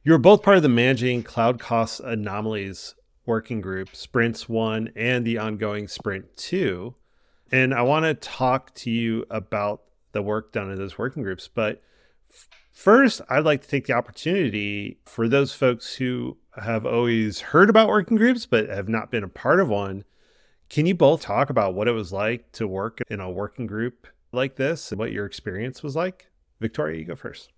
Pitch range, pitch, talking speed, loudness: 105-130 Hz, 115 Hz, 190 wpm, -23 LUFS